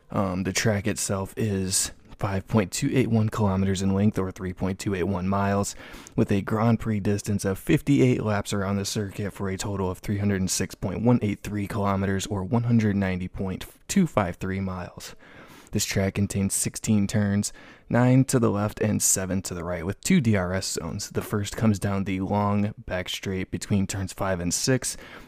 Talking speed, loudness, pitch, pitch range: 150 wpm, -25 LUFS, 100 Hz, 95-110 Hz